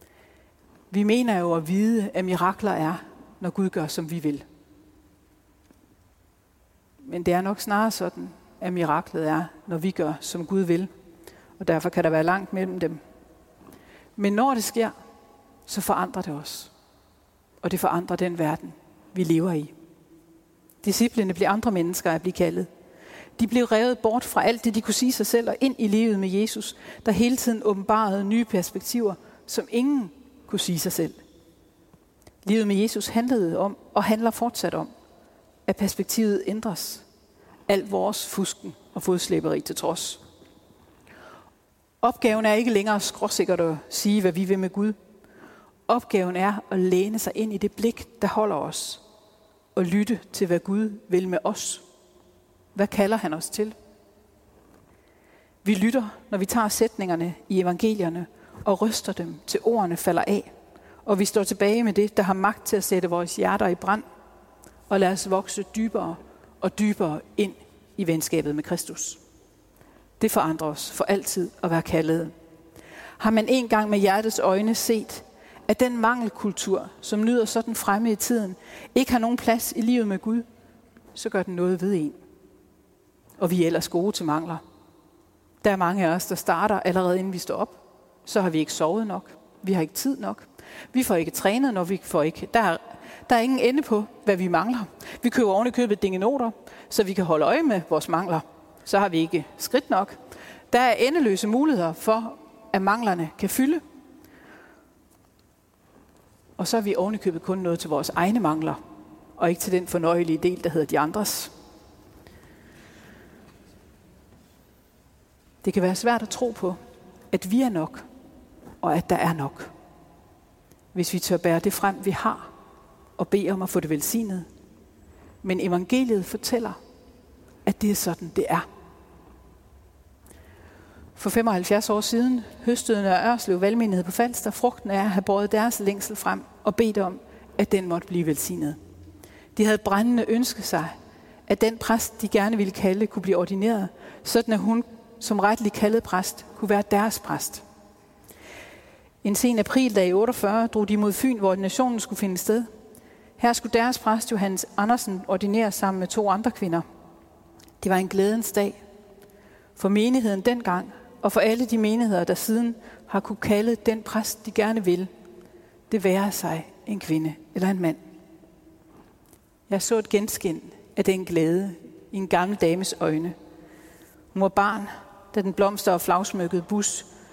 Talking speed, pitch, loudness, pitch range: 170 wpm, 200 Hz, -24 LUFS, 175-220 Hz